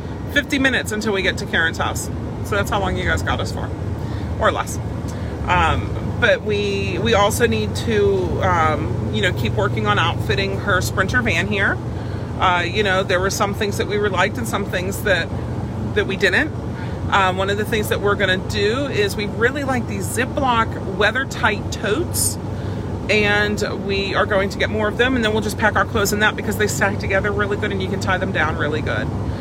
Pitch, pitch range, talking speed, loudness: 105 Hz, 100-110 Hz, 210 wpm, -19 LUFS